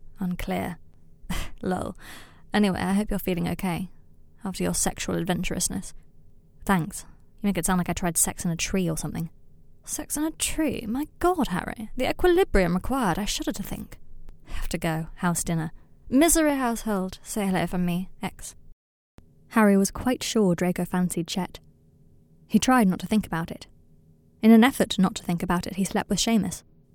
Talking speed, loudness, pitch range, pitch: 175 wpm, -25 LUFS, 170-220 Hz, 185 Hz